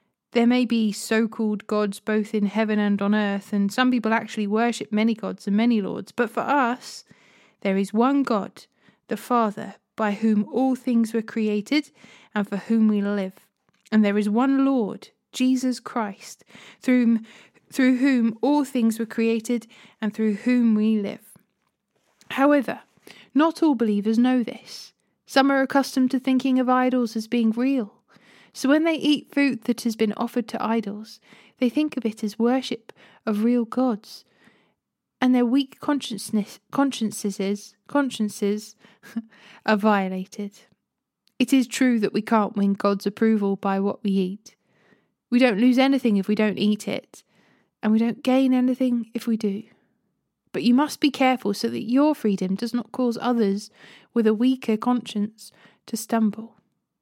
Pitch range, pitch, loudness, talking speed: 210-250 Hz, 230 Hz, -23 LUFS, 160 wpm